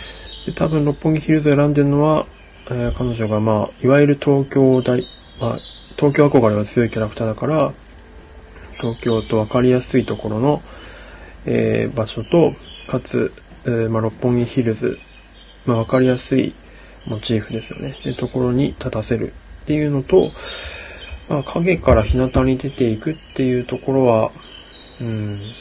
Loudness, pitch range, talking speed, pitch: -19 LUFS, 110-135 Hz, 305 characters per minute, 125 Hz